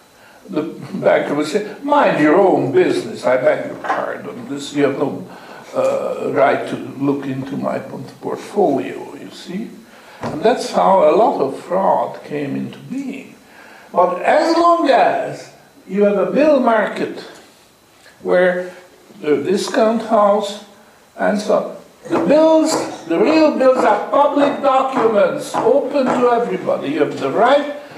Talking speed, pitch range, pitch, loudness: 145 wpm, 180-285 Hz, 225 Hz, -16 LUFS